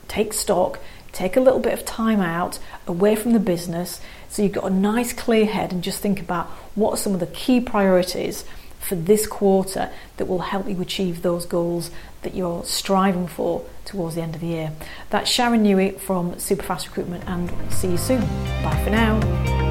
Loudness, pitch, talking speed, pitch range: -22 LUFS, 185 Hz, 195 wpm, 170-205 Hz